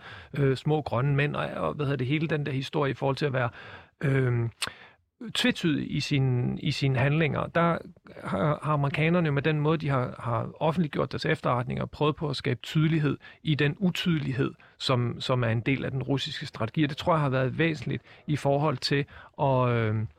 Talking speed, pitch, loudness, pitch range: 195 wpm, 145 Hz, -27 LUFS, 130-155 Hz